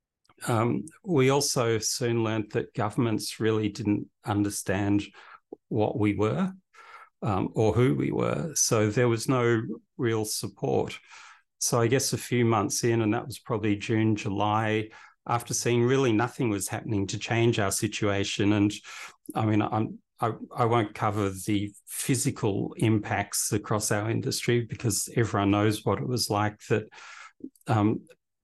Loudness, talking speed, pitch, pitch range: -27 LUFS, 150 wpm, 110 Hz, 105-125 Hz